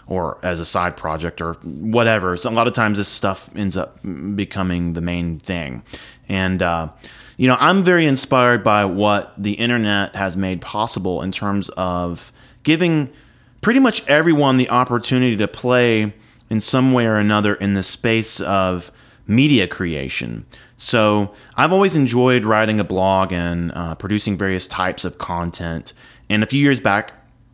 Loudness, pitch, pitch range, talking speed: -18 LUFS, 105 Hz, 95-125 Hz, 165 wpm